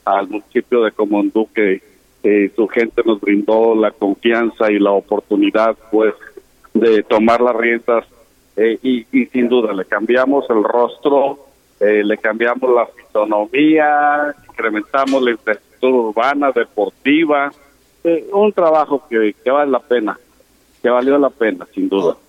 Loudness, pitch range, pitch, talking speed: -15 LUFS, 110-140 Hz, 120 Hz, 145 wpm